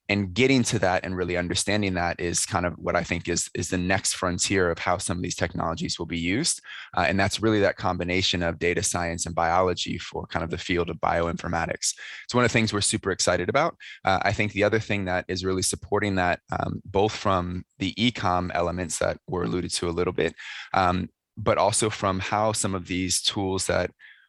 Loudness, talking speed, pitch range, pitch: -25 LUFS, 220 wpm, 90-100 Hz, 90 Hz